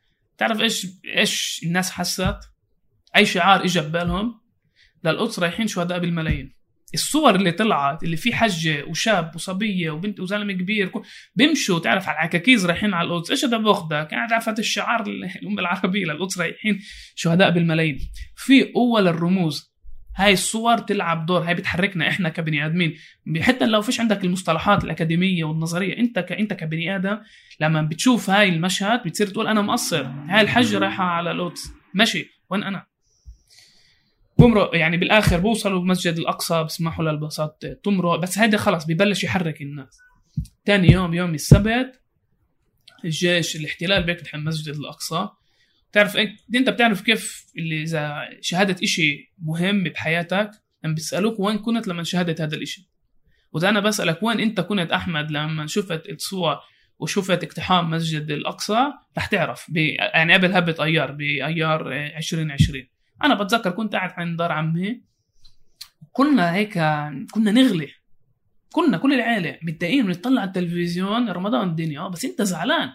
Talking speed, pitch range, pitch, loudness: 140 wpm, 160-210 Hz, 180 Hz, -21 LUFS